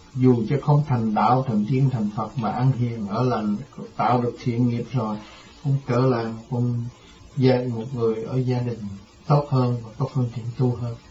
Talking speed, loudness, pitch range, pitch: 195 wpm, -23 LUFS, 110-130 Hz, 120 Hz